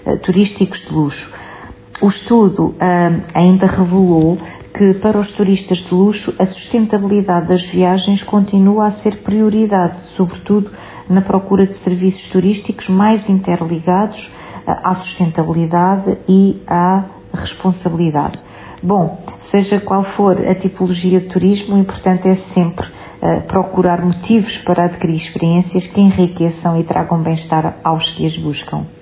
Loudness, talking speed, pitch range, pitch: -14 LUFS, 130 wpm, 175-200 Hz, 185 Hz